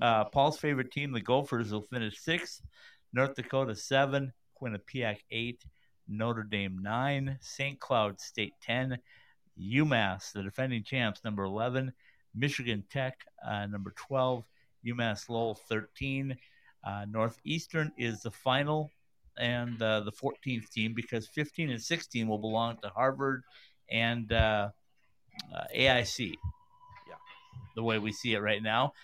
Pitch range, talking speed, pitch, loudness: 110-135 Hz, 135 wpm, 120 Hz, -33 LUFS